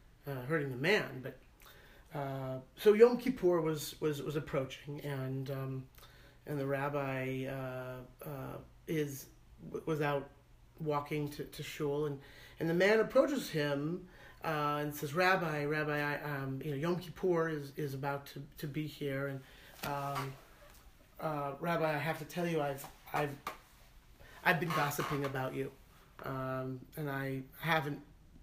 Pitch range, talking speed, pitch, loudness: 135-155 Hz, 150 wpm, 145 Hz, -36 LUFS